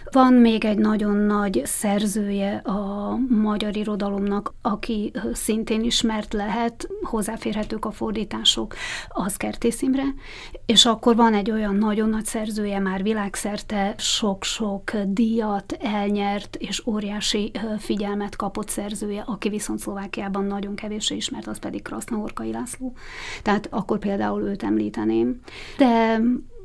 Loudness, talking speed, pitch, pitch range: -23 LUFS, 120 wpm, 210 Hz, 200-230 Hz